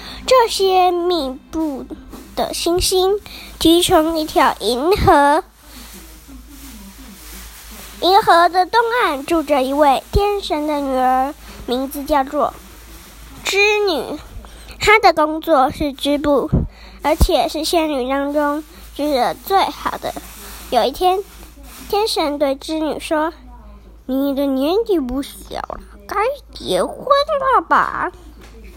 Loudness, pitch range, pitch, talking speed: -17 LUFS, 280-370 Hz, 310 Hz, 150 characters per minute